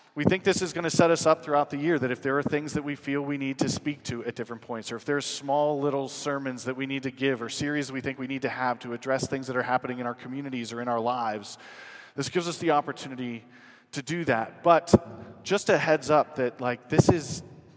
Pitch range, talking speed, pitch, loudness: 125-150 Hz, 260 wpm, 135 Hz, -27 LUFS